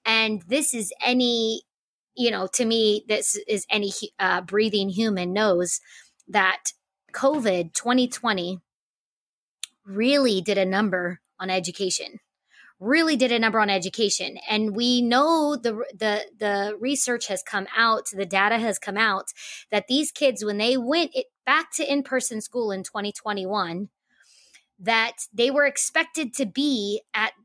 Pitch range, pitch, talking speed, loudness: 200-250 Hz, 220 Hz, 150 wpm, -23 LUFS